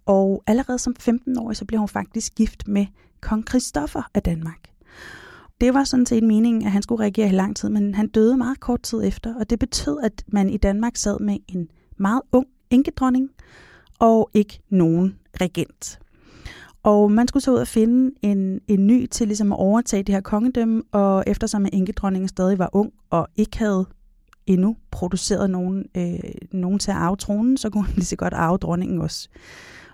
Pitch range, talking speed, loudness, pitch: 195-235 Hz, 190 wpm, -21 LUFS, 210 Hz